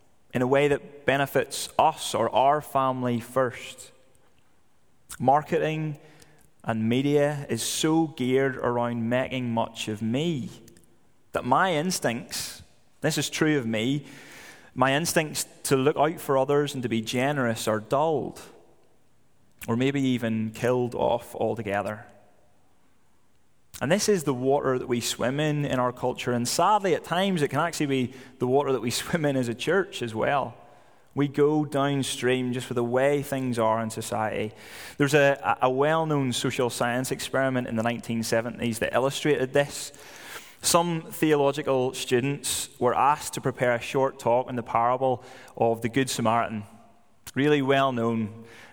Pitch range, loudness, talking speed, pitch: 120-145 Hz, -26 LUFS, 155 wpm, 130 Hz